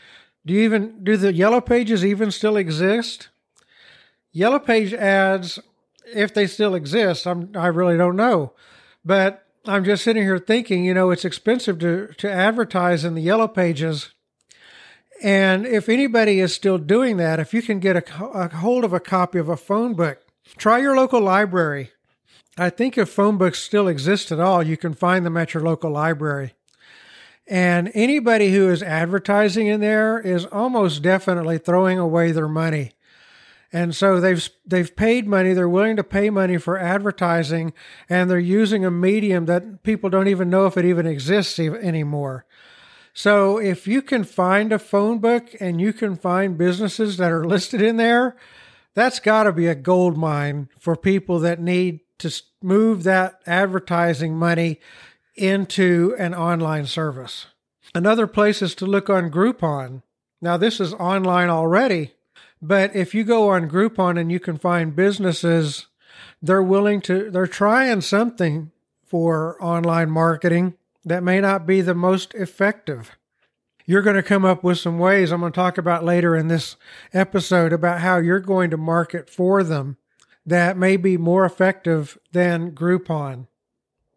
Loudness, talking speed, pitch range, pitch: -19 LUFS, 165 wpm, 170-205 Hz, 185 Hz